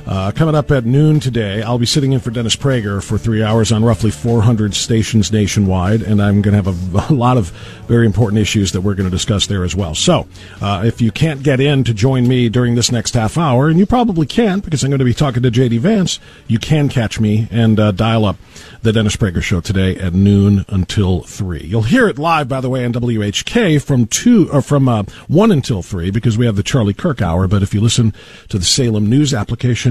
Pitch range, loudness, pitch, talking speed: 105-135 Hz, -14 LUFS, 115 Hz, 240 wpm